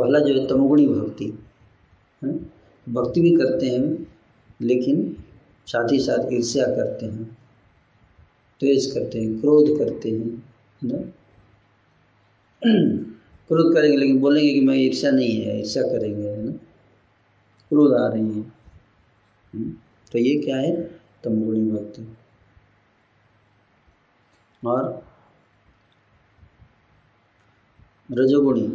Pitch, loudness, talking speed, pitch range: 110 Hz, -21 LUFS, 105 wpm, 105-135 Hz